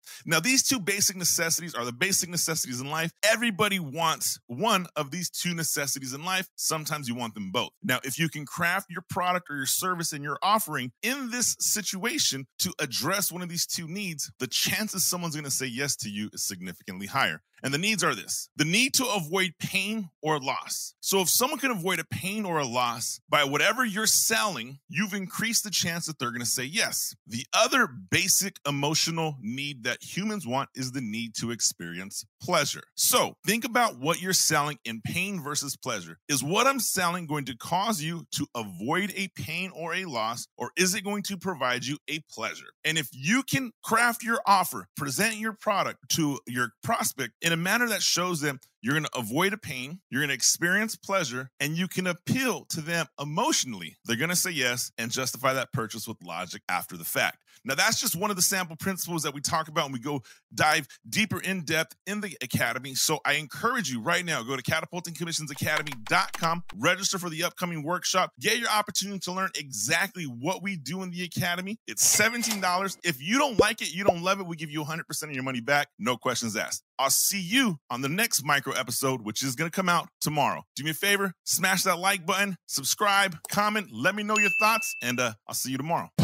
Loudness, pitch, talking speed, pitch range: -27 LUFS, 165 Hz, 210 wpm, 140-195 Hz